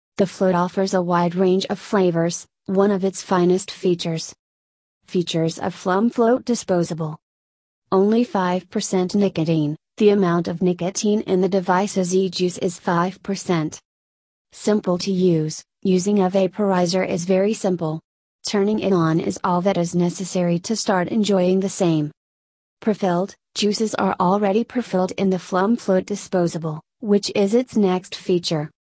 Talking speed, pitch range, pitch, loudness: 145 wpm, 170-195 Hz, 185 Hz, -21 LUFS